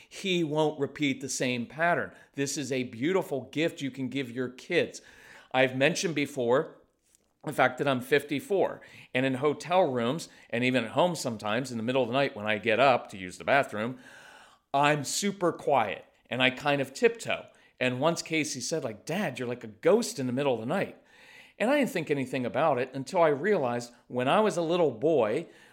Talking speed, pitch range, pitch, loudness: 205 wpm, 125-165 Hz, 140 Hz, -28 LUFS